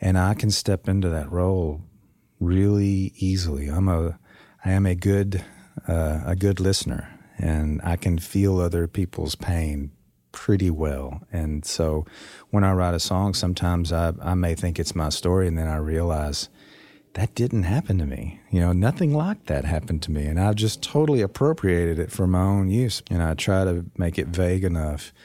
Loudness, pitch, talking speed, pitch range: -24 LUFS, 90 Hz, 190 wpm, 80-100 Hz